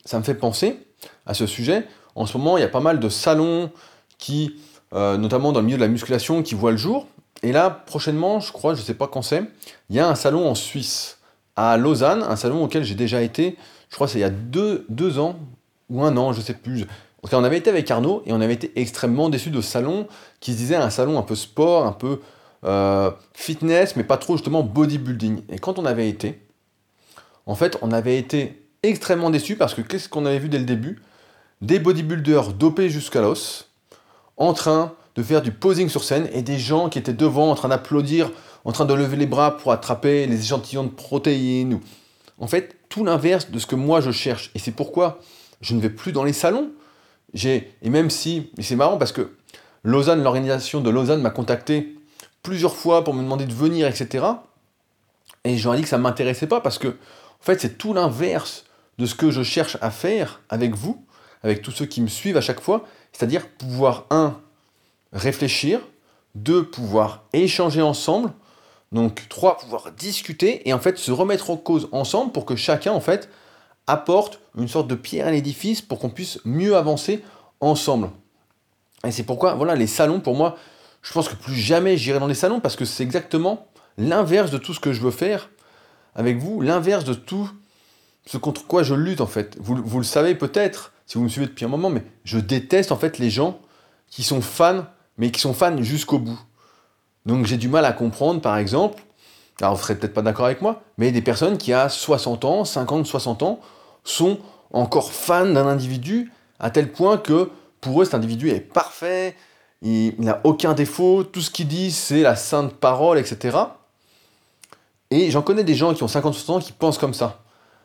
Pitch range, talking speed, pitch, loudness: 120-165 Hz, 210 wpm, 140 Hz, -21 LUFS